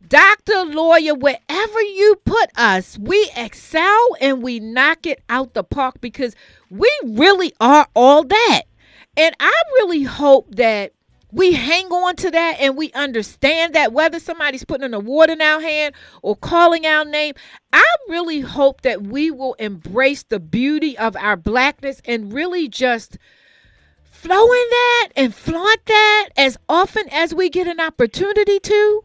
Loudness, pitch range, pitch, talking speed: -15 LUFS, 260-360 Hz, 305 Hz, 155 wpm